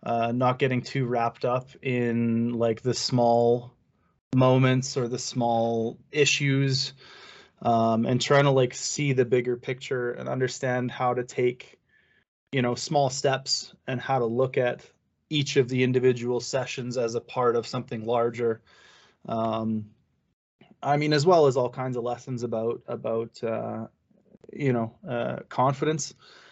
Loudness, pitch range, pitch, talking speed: -26 LUFS, 120-130 Hz, 125 Hz, 150 wpm